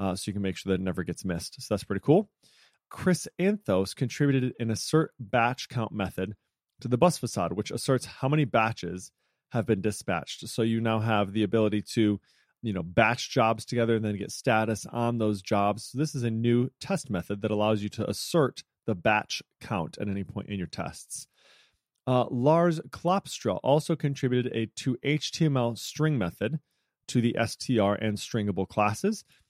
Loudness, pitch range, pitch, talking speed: -28 LUFS, 105-130 Hz, 115 Hz, 185 wpm